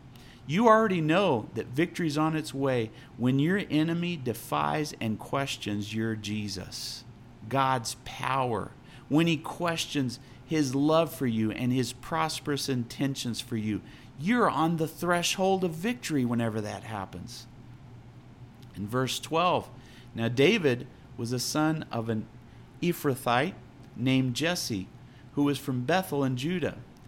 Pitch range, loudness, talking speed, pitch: 120-155 Hz, -29 LUFS, 130 wpm, 130 Hz